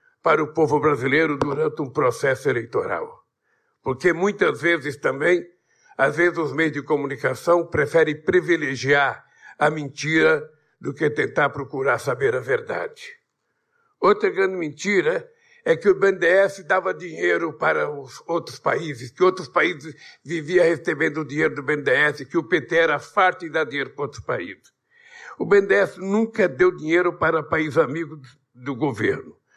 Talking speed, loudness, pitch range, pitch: 145 wpm, -21 LUFS, 150-220 Hz, 170 Hz